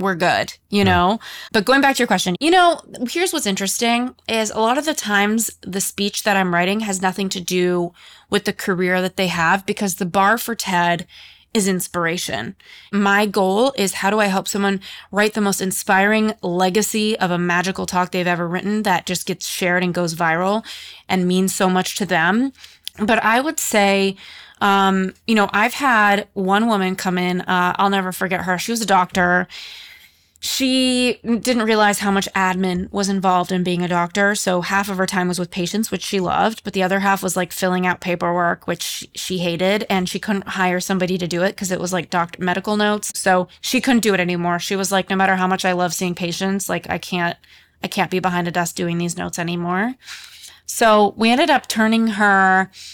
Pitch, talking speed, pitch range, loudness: 195 Hz, 210 wpm, 180-210 Hz, -18 LUFS